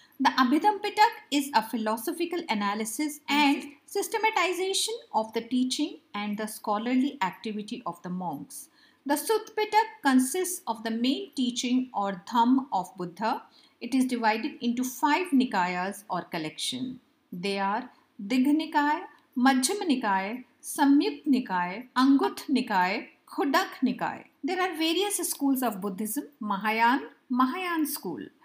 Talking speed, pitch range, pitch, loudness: 125 wpm, 220-305 Hz, 255 Hz, -27 LUFS